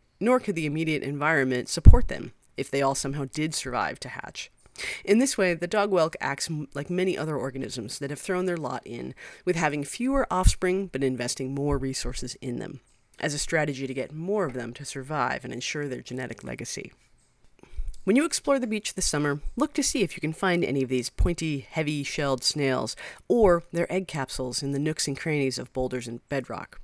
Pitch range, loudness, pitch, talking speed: 135-175 Hz, -27 LUFS, 145 Hz, 205 wpm